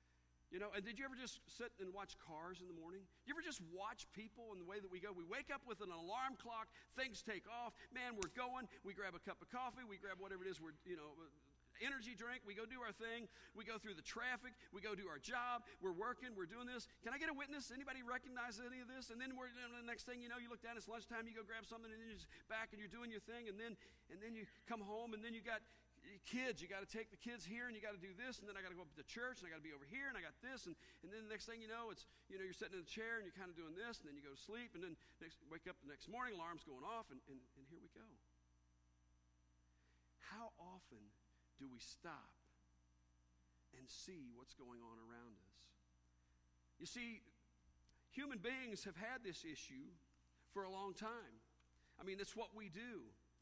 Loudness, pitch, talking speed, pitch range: -52 LUFS, 210 Hz, 265 wpm, 160-235 Hz